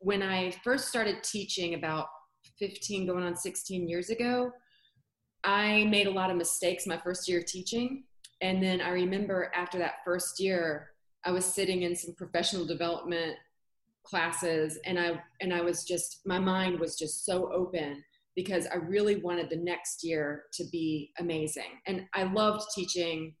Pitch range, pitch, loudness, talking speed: 170-190 Hz, 180 Hz, -31 LUFS, 165 wpm